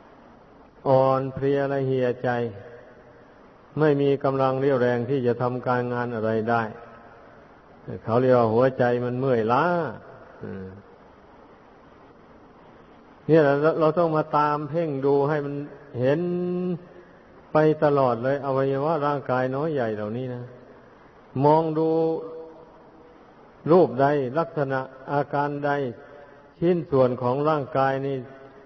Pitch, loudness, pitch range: 135 Hz, -23 LUFS, 125-150 Hz